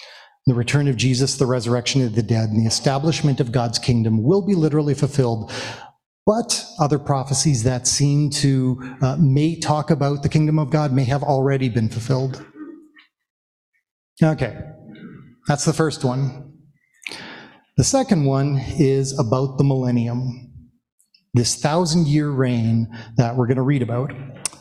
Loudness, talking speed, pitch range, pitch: -20 LUFS, 145 wpm, 125-150 Hz, 135 Hz